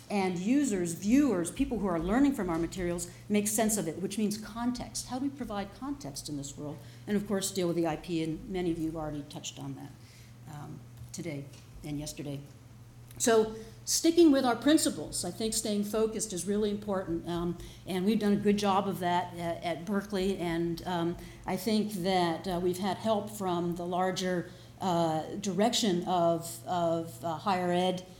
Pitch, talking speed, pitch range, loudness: 180 Hz, 185 wpm, 160-205 Hz, -31 LUFS